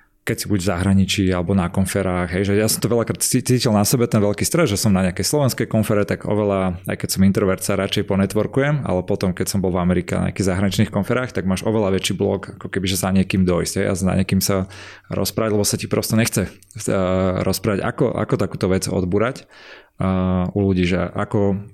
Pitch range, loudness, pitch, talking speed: 95-110 Hz, -20 LUFS, 100 Hz, 220 wpm